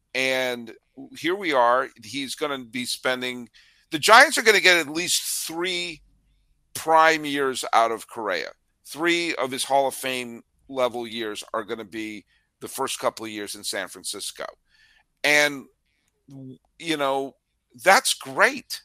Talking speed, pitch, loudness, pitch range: 155 wpm, 135 Hz, -22 LUFS, 125-170 Hz